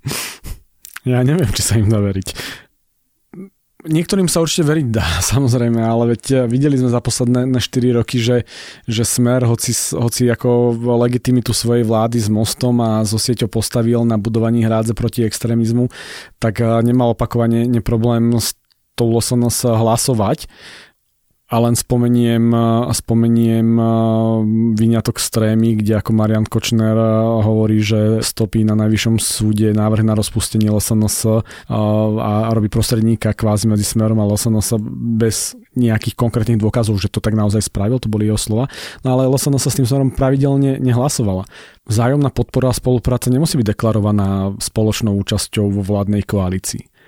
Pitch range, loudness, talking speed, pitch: 110-120 Hz, -16 LUFS, 140 wpm, 115 Hz